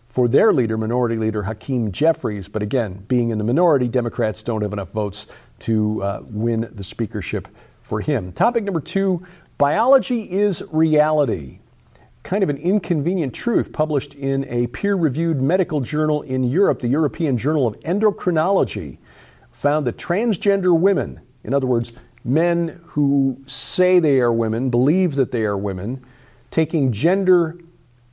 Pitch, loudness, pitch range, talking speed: 135 Hz, -20 LUFS, 115-170 Hz, 150 wpm